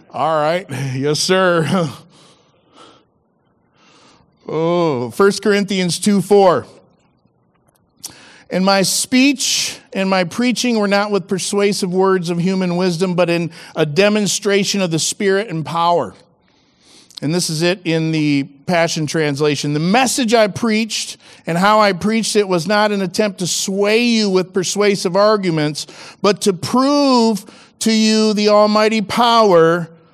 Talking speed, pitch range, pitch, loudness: 130 wpm, 170-210 Hz, 190 Hz, -15 LUFS